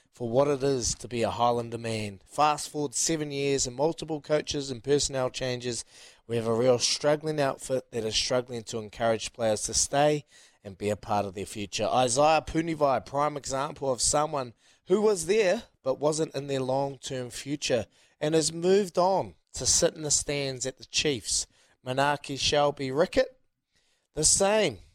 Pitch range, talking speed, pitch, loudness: 115-150 Hz, 175 wpm, 135 Hz, -27 LUFS